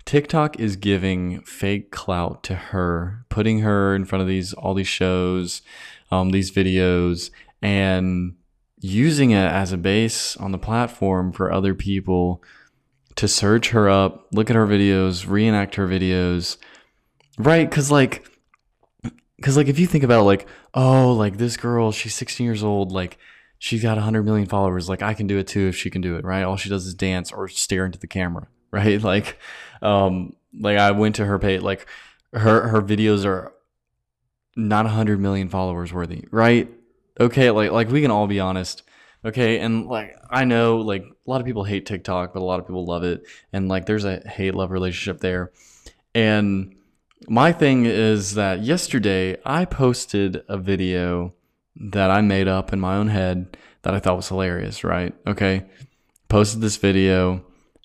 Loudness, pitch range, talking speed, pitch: -21 LUFS, 95-110 Hz, 180 wpm, 100 Hz